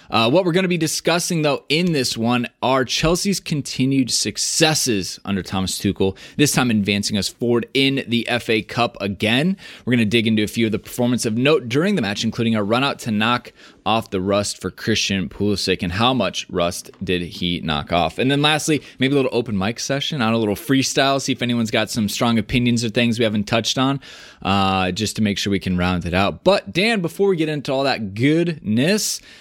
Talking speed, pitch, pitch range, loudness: 220 wpm, 120 Hz, 105-140 Hz, -19 LUFS